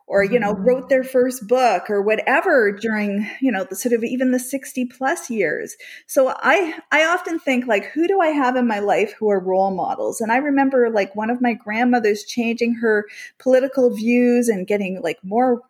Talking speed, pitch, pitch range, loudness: 205 wpm, 245 Hz, 210-260 Hz, -19 LUFS